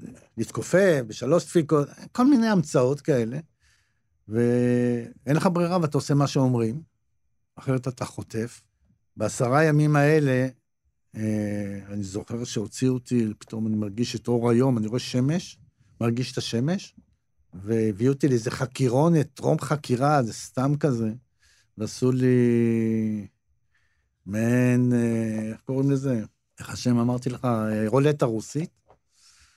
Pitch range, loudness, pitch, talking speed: 110-140 Hz, -24 LUFS, 125 Hz, 120 wpm